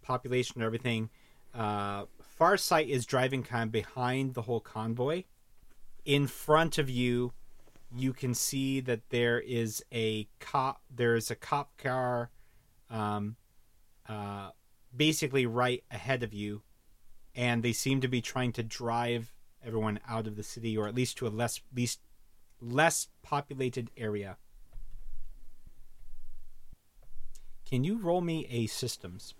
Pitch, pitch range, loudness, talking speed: 120 Hz, 110-130 Hz, -32 LUFS, 135 wpm